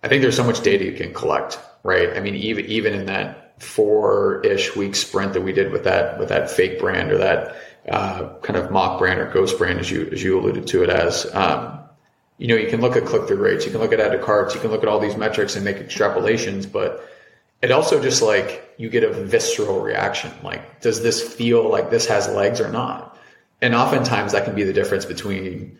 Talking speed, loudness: 235 wpm, -20 LUFS